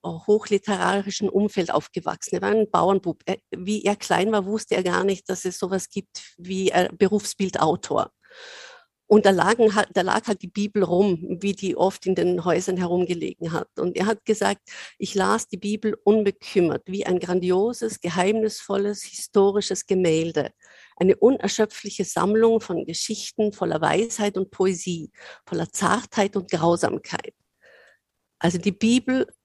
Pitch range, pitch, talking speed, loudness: 185-210 Hz, 200 Hz, 145 wpm, -23 LUFS